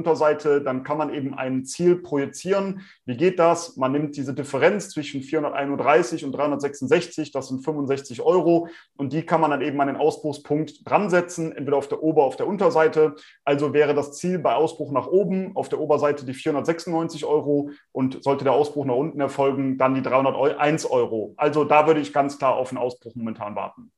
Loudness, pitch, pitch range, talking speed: -23 LUFS, 145 Hz, 140-160 Hz, 190 wpm